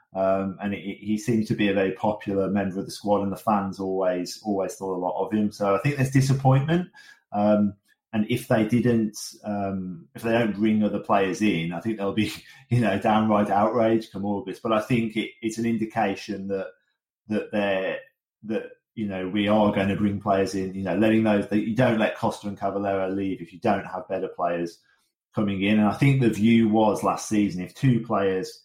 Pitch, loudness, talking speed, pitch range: 105 Hz, -24 LUFS, 220 wpm, 95-110 Hz